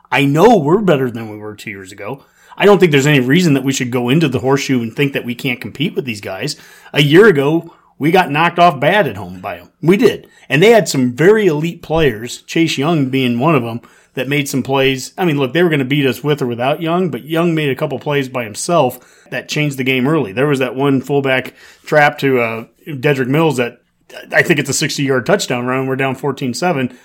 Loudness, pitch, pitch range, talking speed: -14 LUFS, 140 Hz, 130-160 Hz, 245 wpm